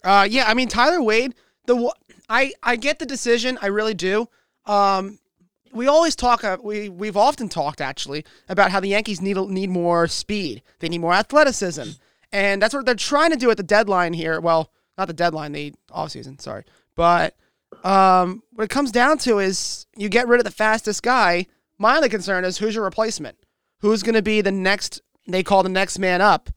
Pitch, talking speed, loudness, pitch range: 205 Hz, 200 wpm, -20 LUFS, 185-235 Hz